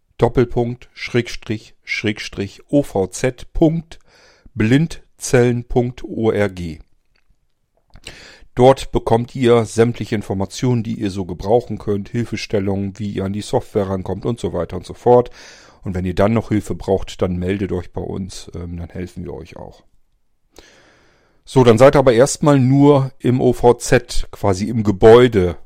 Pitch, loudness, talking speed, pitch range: 110 Hz, -17 LUFS, 130 wpm, 95-120 Hz